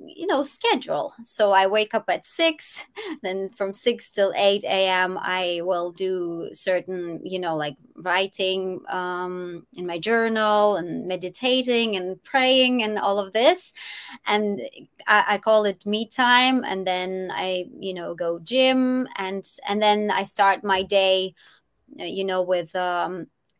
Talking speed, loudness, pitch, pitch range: 155 wpm, -22 LUFS, 195 Hz, 185-230 Hz